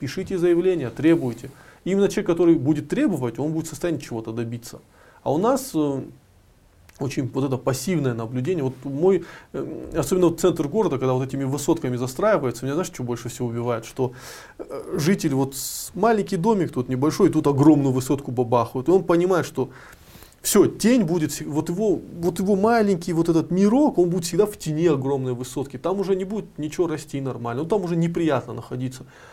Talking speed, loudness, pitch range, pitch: 175 wpm, -22 LUFS, 130-180 Hz, 155 Hz